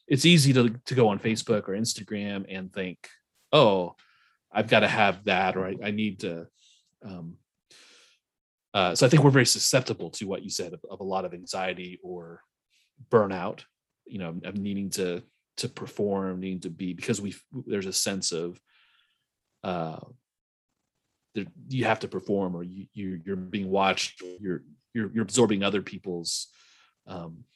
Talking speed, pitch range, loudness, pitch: 165 wpm, 90-110 Hz, -26 LUFS, 95 Hz